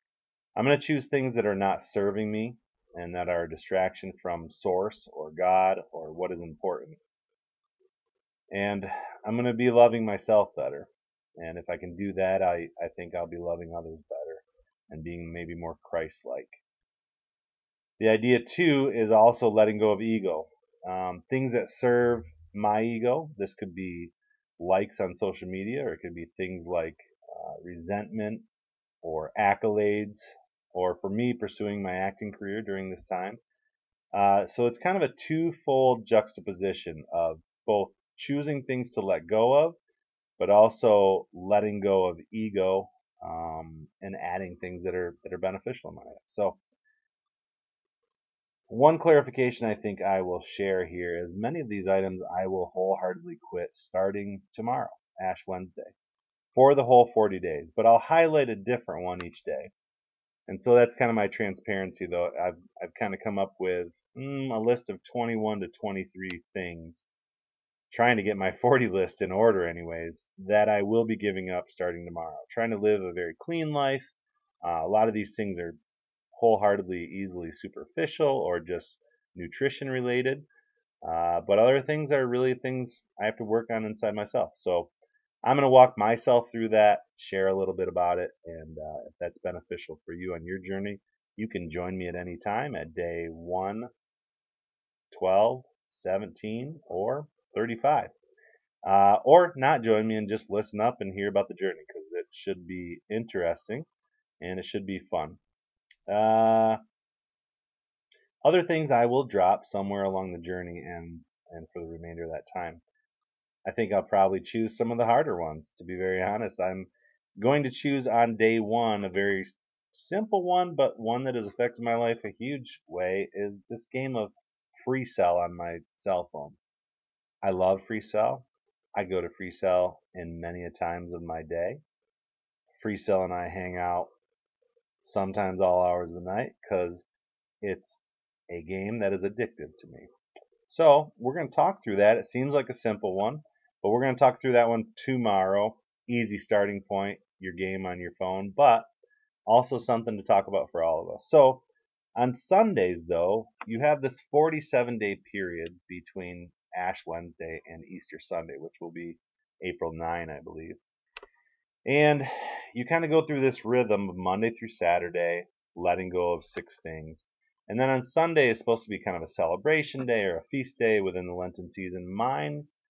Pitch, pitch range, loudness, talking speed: 105 Hz, 90-130 Hz, -28 LUFS, 175 wpm